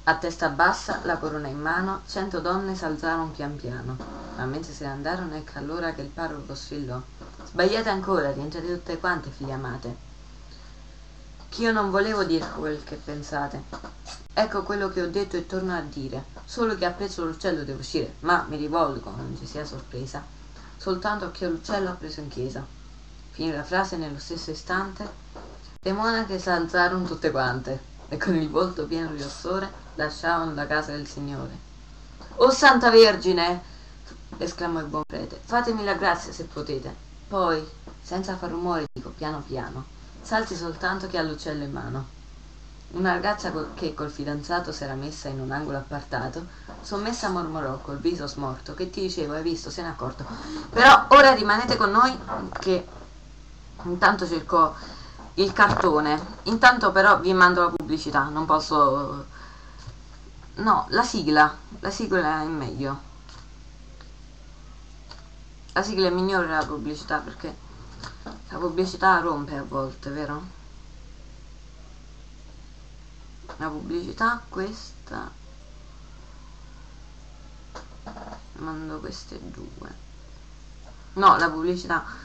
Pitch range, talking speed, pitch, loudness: 140-180 Hz, 140 wpm, 155 Hz, -24 LUFS